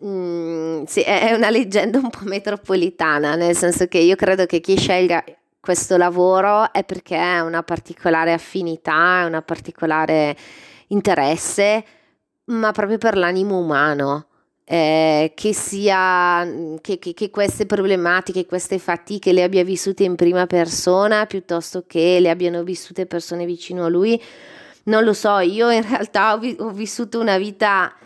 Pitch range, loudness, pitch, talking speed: 170-205 Hz, -18 LUFS, 180 Hz, 150 wpm